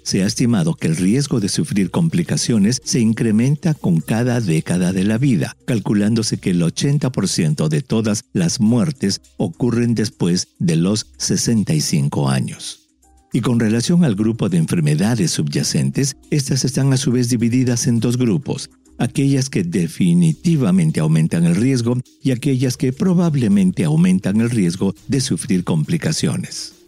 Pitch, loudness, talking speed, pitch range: 140 Hz, -17 LUFS, 145 wpm, 120-170 Hz